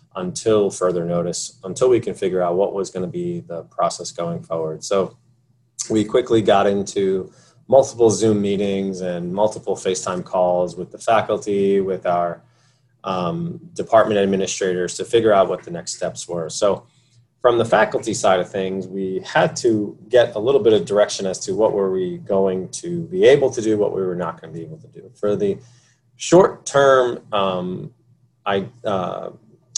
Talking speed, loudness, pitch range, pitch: 180 wpm, -20 LUFS, 95-125 Hz, 105 Hz